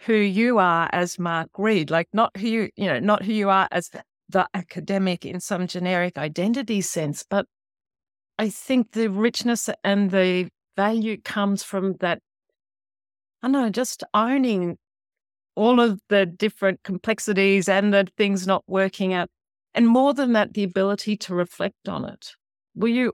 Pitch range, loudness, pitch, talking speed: 180-220 Hz, -22 LUFS, 200 Hz, 165 wpm